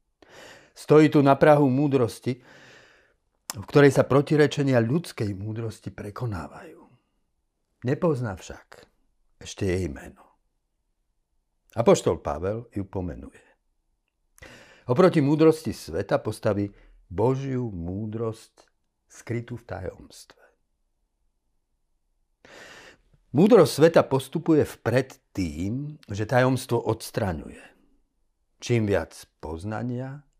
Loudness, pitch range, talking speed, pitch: -24 LUFS, 105-145 Hz, 80 wpm, 120 Hz